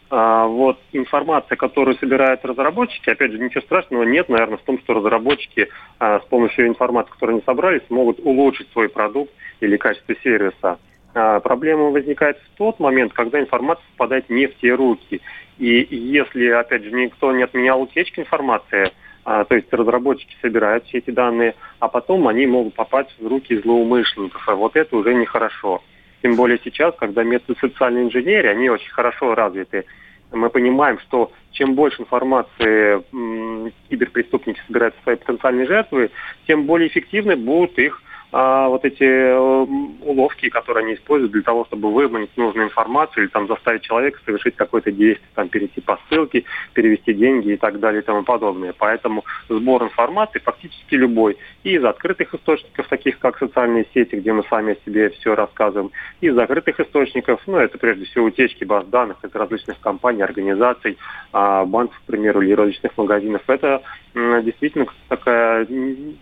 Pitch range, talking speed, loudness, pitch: 115-135 Hz, 160 wpm, -18 LUFS, 125 Hz